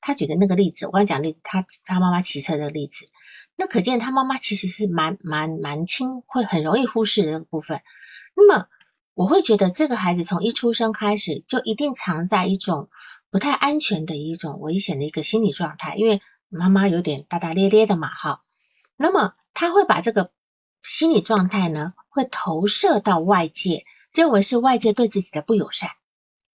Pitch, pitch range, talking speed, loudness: 200 Hz, 170-230 Hz, 290 characters per minute, -20 LUFS